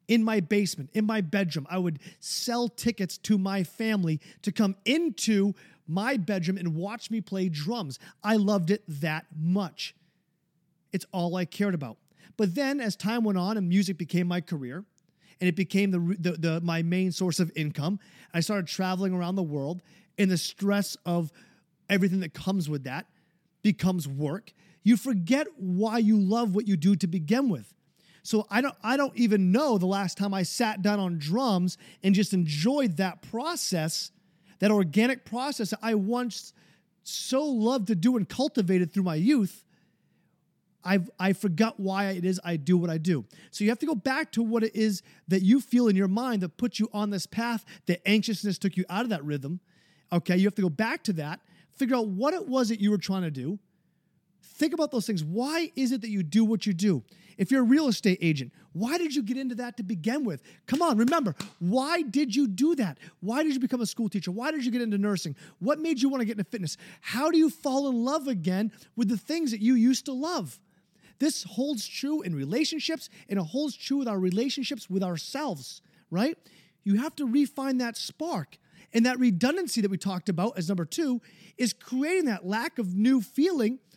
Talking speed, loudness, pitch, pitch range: 205 wpm, -28 LUFS, 200 Hz, 180-240 Hz